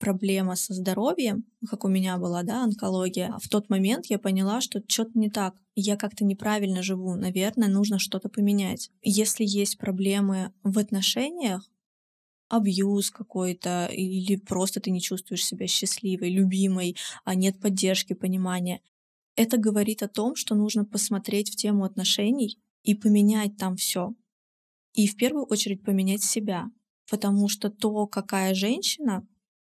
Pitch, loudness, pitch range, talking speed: 205 Hz, -26 LUFS, 190-215 Hz, 140 wpm